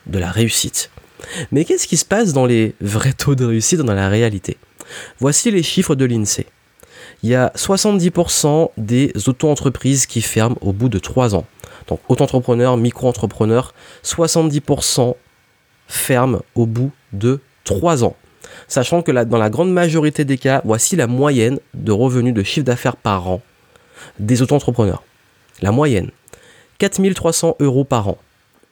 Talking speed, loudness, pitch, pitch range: 150 wpm, -16 LUFS, 130 Hz, 115-145 Hz